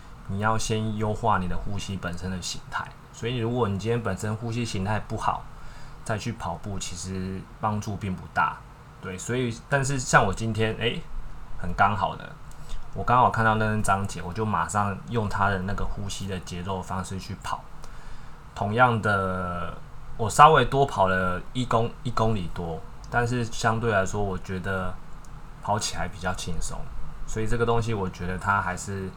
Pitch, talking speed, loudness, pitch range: 105 Hz, 255 characters per minute, -26 LUFS, 95-115 Hz